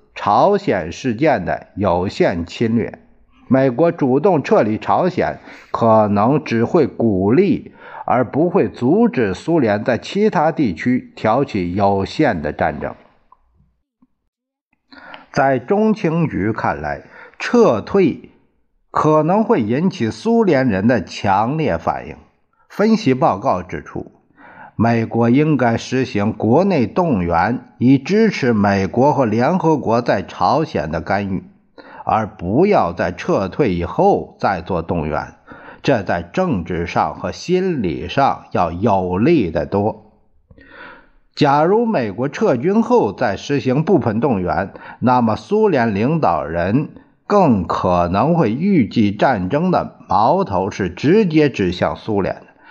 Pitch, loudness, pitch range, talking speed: 135 Hz, -17 LUFS, 110-185 Hz, 180 characters per minute